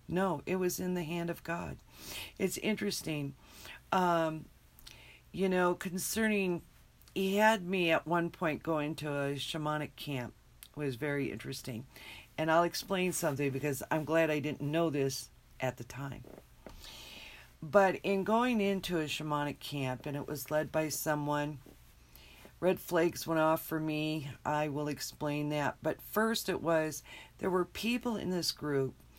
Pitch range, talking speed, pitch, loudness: 145-180 Hz, 155 wpm, 155 Hz, -34 LUFS